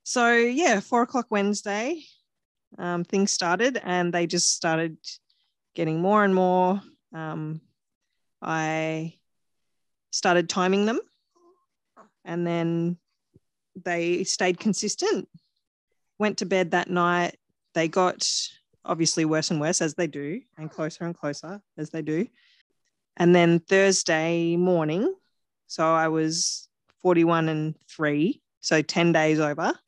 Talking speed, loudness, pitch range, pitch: 120 wpm, -24 LUFS, 160-205 Hz, 175 Hz